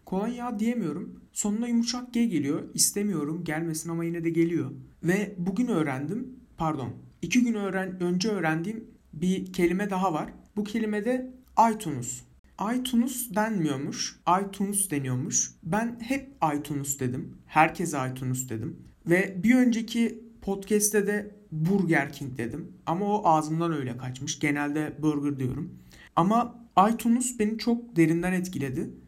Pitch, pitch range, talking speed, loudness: 180 Hz, 150-220 Hz, 130 wpm, -27 LUFS